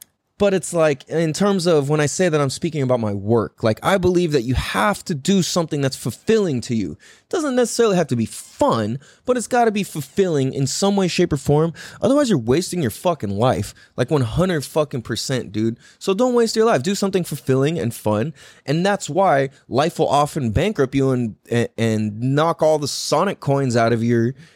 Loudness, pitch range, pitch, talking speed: -20 LUFS, 125-185 Hz, 150 Hz, 210 wpm